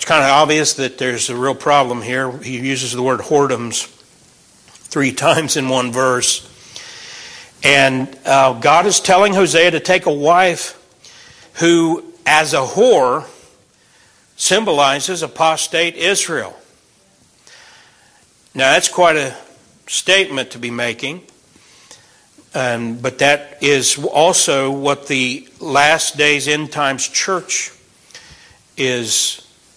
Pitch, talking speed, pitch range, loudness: 140 Hz, 115 wpm, 125-160 Hz, -14 LUFS